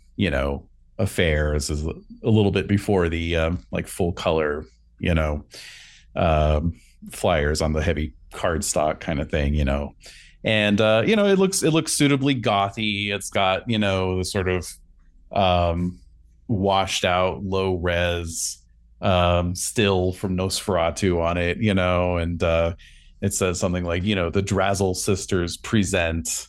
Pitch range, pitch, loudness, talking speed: 80-100 Hz, 90 Hz, -22 LUFS, 155 wpm